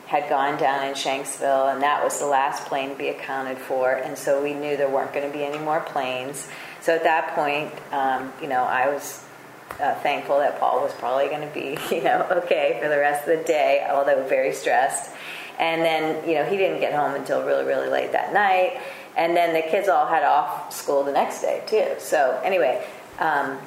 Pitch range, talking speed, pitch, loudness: 135-170 Hz, 220 wpm, 145 Hz, -23 LUFS